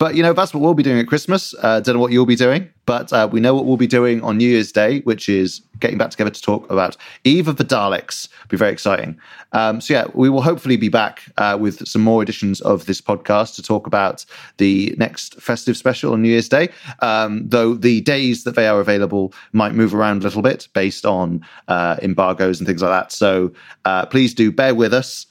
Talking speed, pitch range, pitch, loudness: 240 wpm, 105-130 Hz, 115 Hz, -17 LUFS